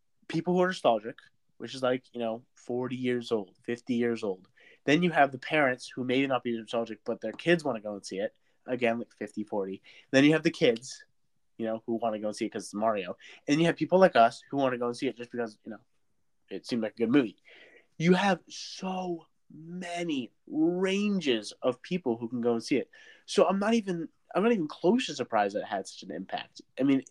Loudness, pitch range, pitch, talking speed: -29 LUFS, 115-170 Hz, 125 Hz, 240 wpm